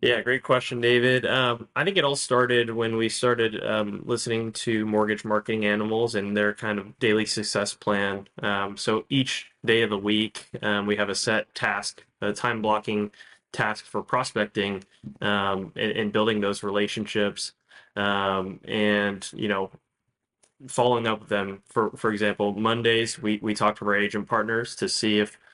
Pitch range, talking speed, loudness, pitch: 105-115 Hz, 170 wpm, -25 LUFS, 105 Hz